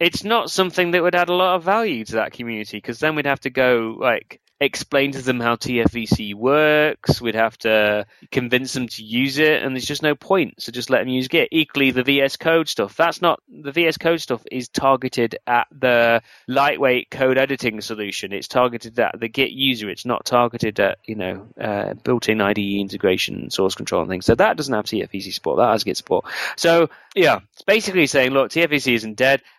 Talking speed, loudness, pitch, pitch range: 210 wpm, -19 LUFS, 130 Hz, 115-150 Hz